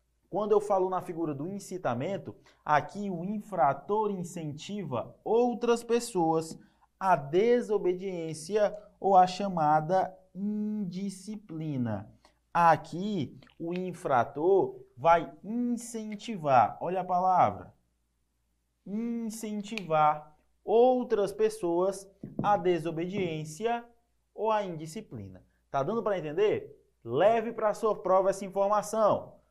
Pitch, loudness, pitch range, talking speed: 195 Hz, -29 LUFS, 165-215 Hz, 95 wpm